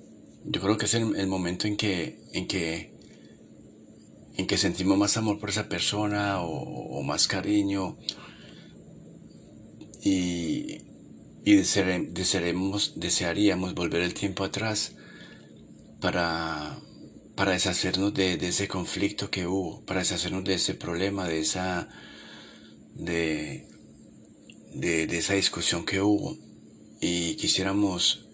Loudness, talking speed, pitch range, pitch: -26 LUFS, 120 wpm, 85-100 Hz, 95 Hz